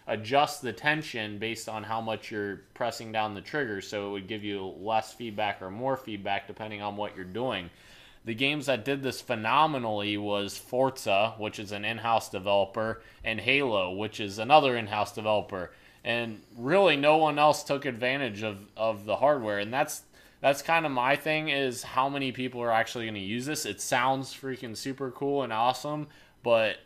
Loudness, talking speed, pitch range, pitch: -29 LUFS, 185 wpm, 105-135 Hz, 115 Hz